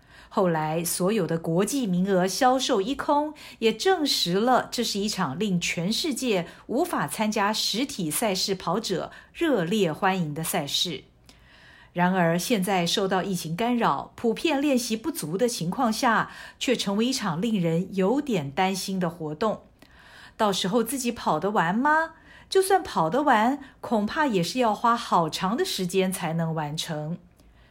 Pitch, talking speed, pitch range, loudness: 200 Hz, 225 characters per minute, 180-240 Hz, -25 LUFS